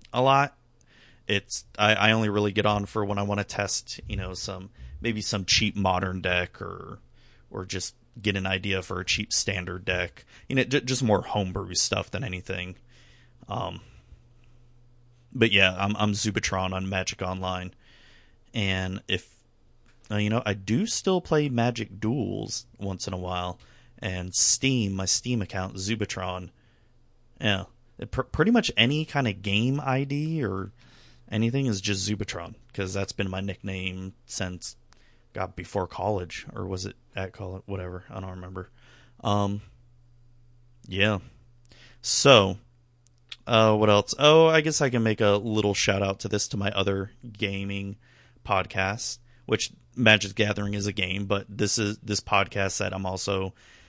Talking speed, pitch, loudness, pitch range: 155 wpm, 105 Hz, -26 LUFS, 95-120 Hz